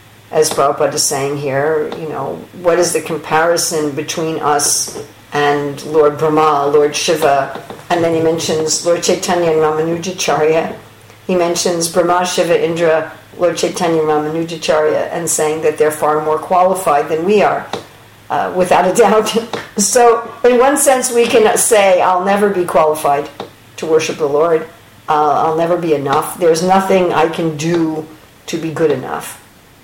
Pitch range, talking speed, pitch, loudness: 155-180 Hz, 155 wpm, 160 Hz, -14 LUFS